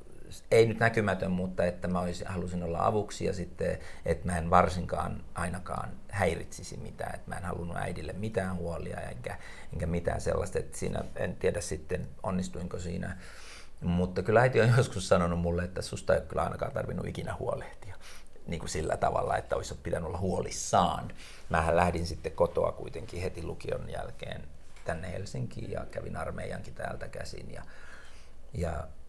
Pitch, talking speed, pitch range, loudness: 90 Hz, 165 wpm, 85-95 Hz, -32 LUFS